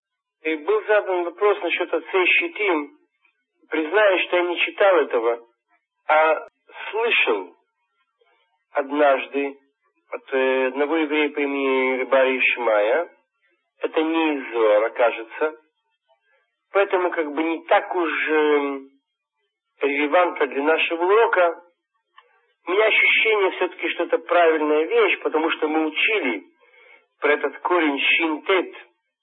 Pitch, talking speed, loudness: 170 Hz, 110 wpm, -20 LUFS